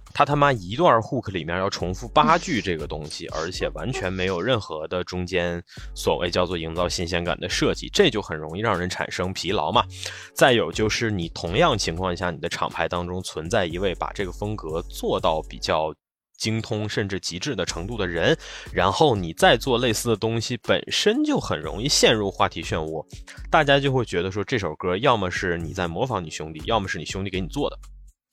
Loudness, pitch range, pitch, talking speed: -23 LUFS, 85-110 Hz, 95 Hz, 310 characters per minute